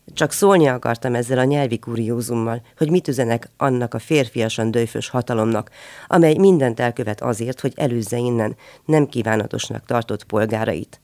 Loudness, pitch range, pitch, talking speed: -20 LUFS, 115-140 Hz, 120 Hz, 140 wpm